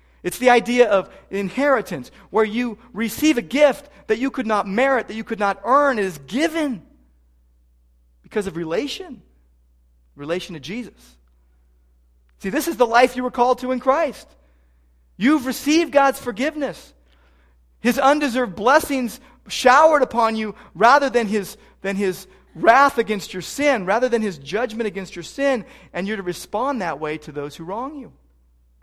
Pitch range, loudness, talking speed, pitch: 155-255 Hz, -20 LUFS, 160 wpm, 215 Hz